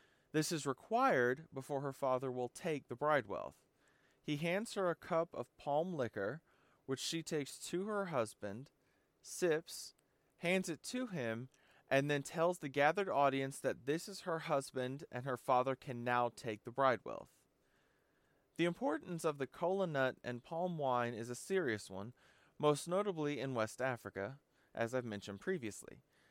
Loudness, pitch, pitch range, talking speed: -39 LUFS, 135 Hz, 125-165 Hz, 160 wpm